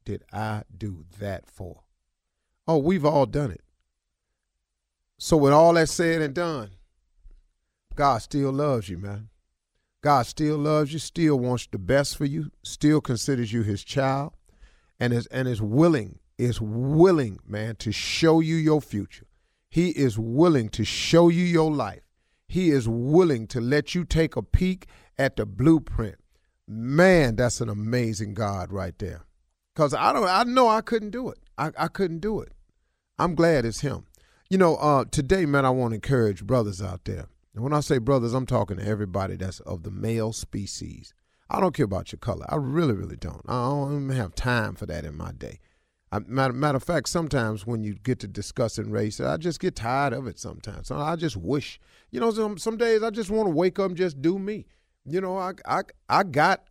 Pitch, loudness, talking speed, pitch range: 125 Hz, -24 LUFS, 195 wpm, 100-155 Hz